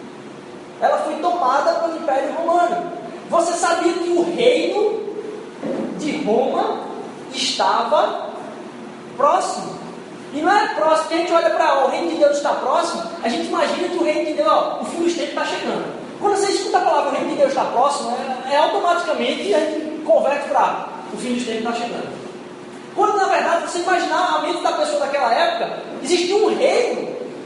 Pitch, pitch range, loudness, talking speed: 335 Hz, 300-360 Hz, -19 LUFS, 185 wpm